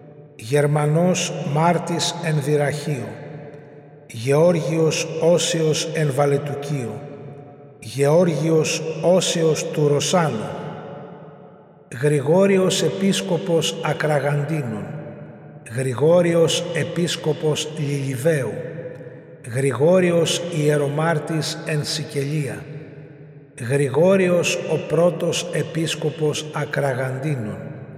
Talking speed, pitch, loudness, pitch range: 55 wpm, 155 Hz, -20 LUFS, 145-165 Hz